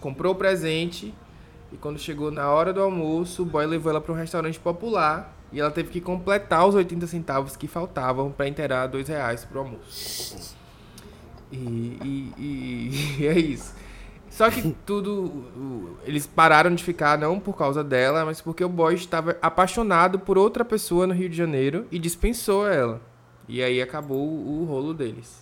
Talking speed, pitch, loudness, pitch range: 175 wpm, 160 Hz, -24 LUFS, 135-180 Hz